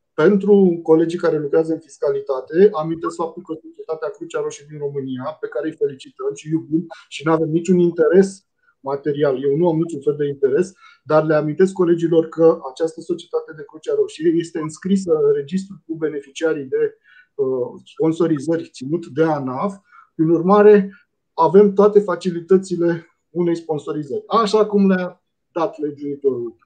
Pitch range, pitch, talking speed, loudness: 160-205 Hz, 175 Hz, 150 wpm, -19 LUFS